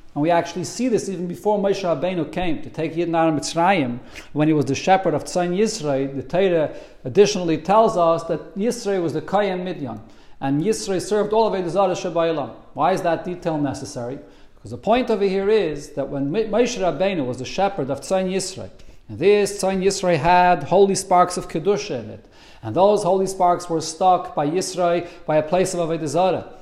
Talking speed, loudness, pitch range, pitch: 195 wpm, -21 LUFS, 155-195 Hz, 175 Hz